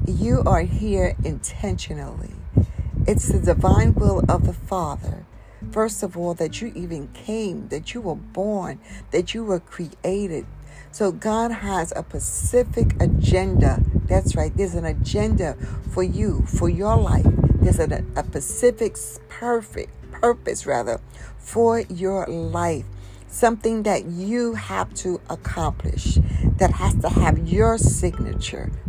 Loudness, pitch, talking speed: -22 LUFS, 145 Hz, 135 wpm